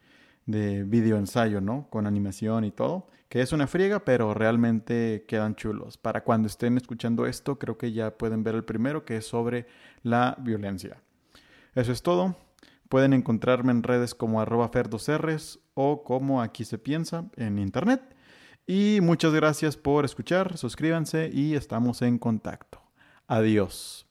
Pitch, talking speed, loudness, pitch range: 120 Hz, 150 wpm, -27 LUFS, 110-145 Hz